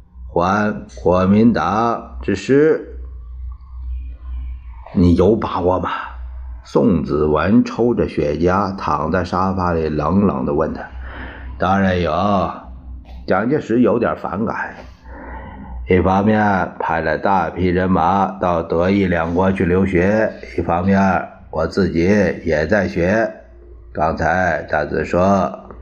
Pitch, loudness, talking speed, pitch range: 90 Hz, -17 LUFS, 160 characters per minute, 65-95 Hz